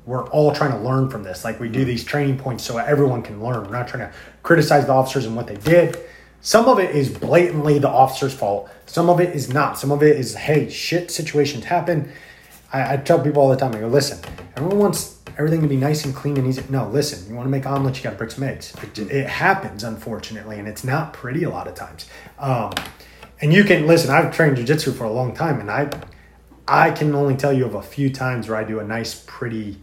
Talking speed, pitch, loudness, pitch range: 245 wpm, 135 Hz, -19 LUFS, 115-150 Hz